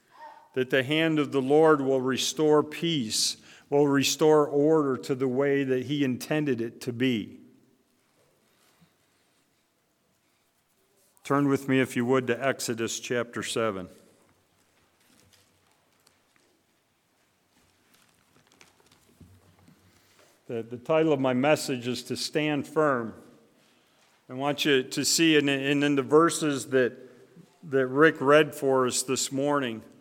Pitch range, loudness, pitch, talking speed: 125-150 Hz, -25 LUFS, 135 Hz, 120 wpm